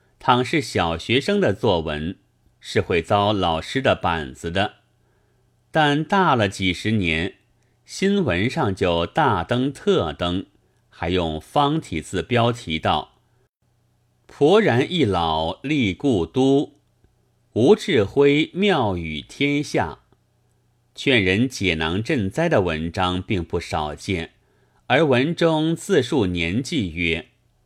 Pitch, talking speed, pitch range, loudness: 120 Hz, 160 characters per minute, 90-130 Hz, -21 LUFS